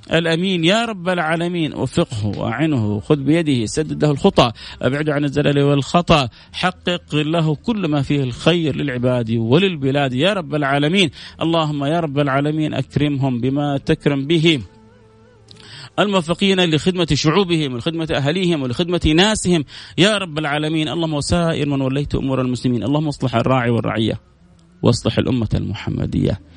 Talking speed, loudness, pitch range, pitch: 130 wpm, -18 LUFS, 125-165 Hz, 145 Hz